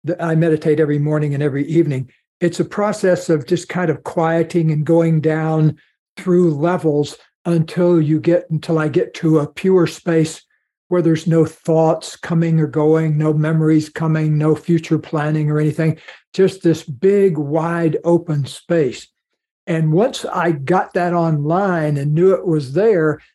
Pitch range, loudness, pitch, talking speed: 155-170 Hz, -17 LUFS, 160 Hz, 160 wpm